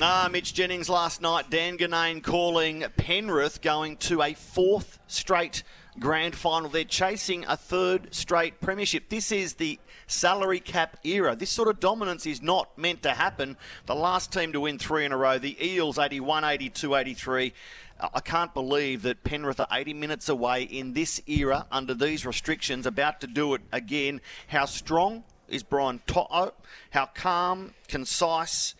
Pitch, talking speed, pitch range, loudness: 160 Hz, 170 wpm, 140-180 Hz, -27 LUFS